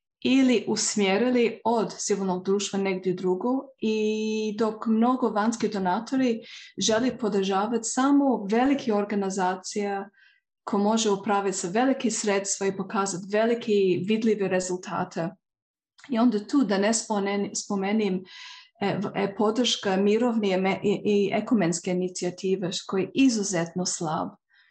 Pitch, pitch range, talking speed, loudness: 205 Hz, 195-230 Hz, 110 wpm, -25 LUFS